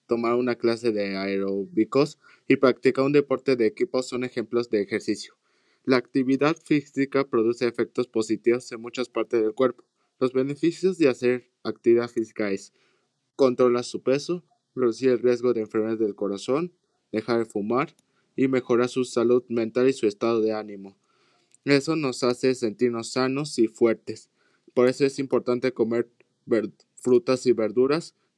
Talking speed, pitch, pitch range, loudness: 150 wpm, 125 Hz, 115-130 Hz, -25 LUFS